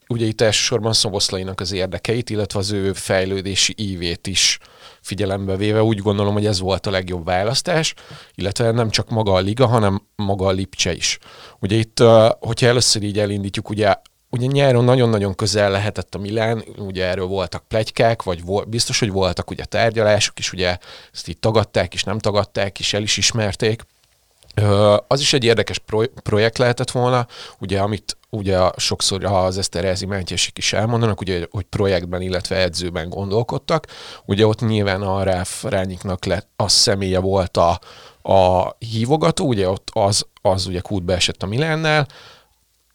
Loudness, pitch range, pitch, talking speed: -19 LUFS, 95-110 Hz, 100 Hz, 165 wpm